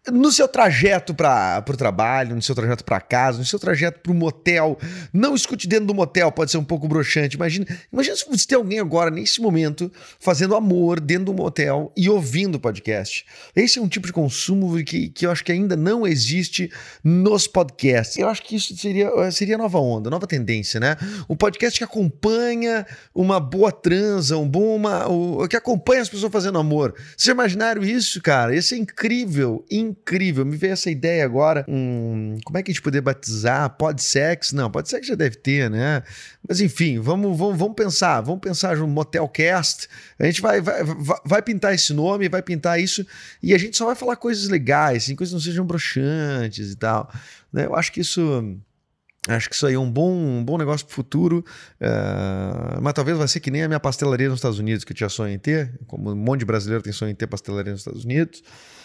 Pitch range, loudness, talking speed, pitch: 135-195 Hz, -20 LUFS, 210 wpm, 165 Hz